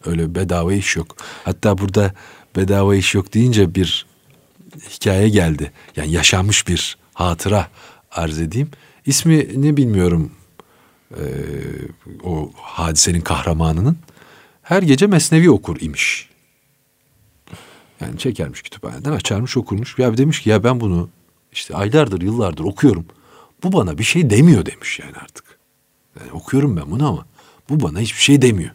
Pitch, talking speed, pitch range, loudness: 100 Hz, 135 wpm, 85-140 Hz, -17 LUFS